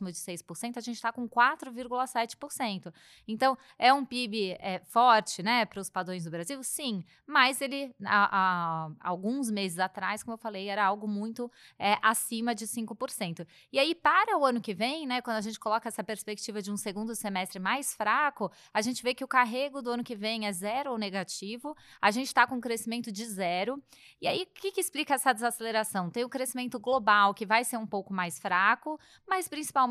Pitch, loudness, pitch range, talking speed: 230 Hz, -30 LUFS, 200-255 Hz, 200 wpm